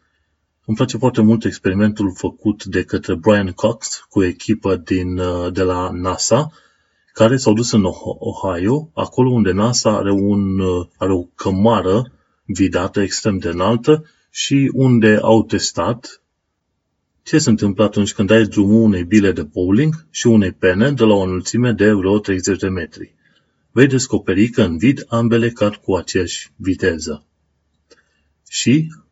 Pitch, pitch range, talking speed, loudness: 105 Hz, 95-115 Hz, 145 wpm, -16 LUFS